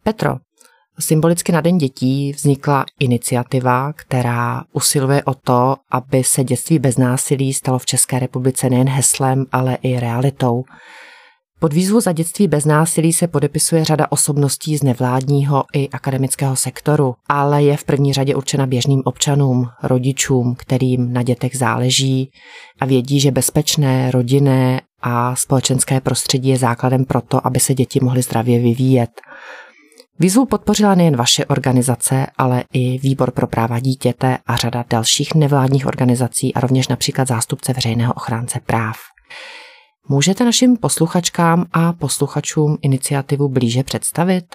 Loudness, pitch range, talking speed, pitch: -16 LUFS, 125-150 Hz, 135 wpm, 135 Hz